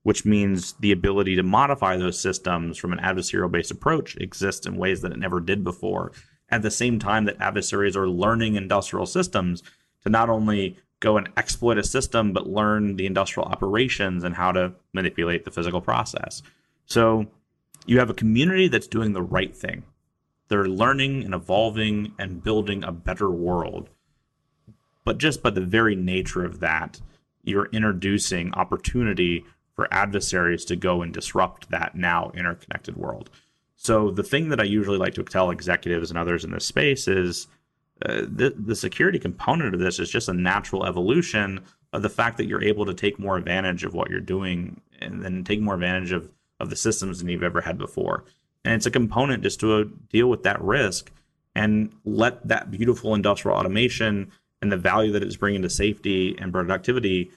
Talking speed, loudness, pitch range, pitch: 180 wpm, -24 LUFS, 90-110 Hz, 100 Hz